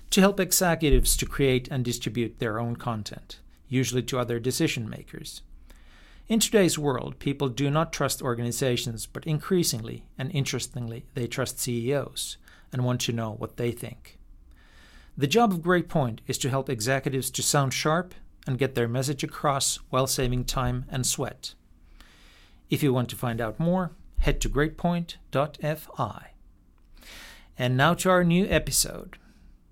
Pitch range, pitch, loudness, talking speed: 120-150 Hz, 130 Hz, -26 LUFS, 150 wpm